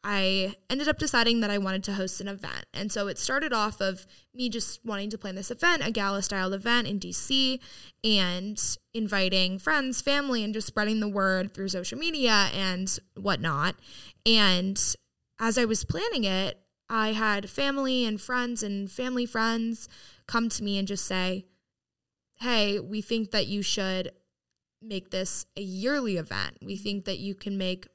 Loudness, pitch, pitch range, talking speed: -27 LUFS, 205 Hz, 195-230 Hz, 175 wpm